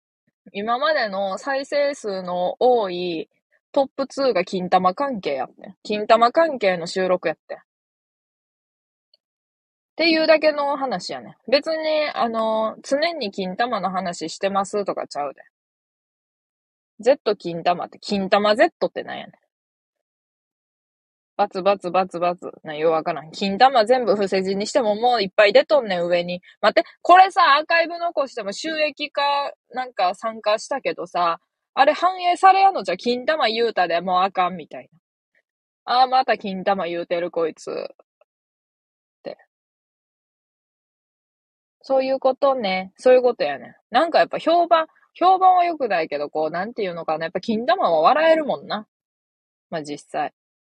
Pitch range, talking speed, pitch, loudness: 185-290 Hz, 285 characters per minute, 225 Hz, -20 LUFS